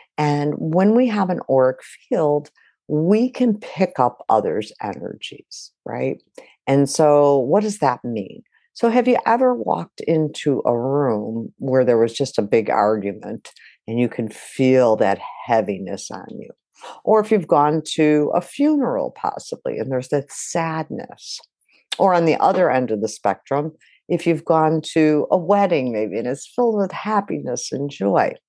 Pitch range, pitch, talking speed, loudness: 130-200 Hz, 155 Hz, 160 wpm, -19 LUFS